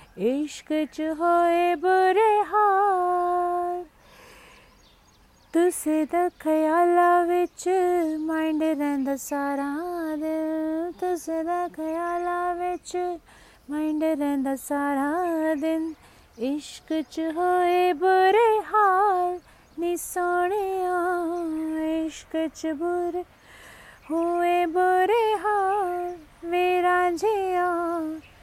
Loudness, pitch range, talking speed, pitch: -24 LUFS, 315-360 Hz, 60 wpm, 345 Hz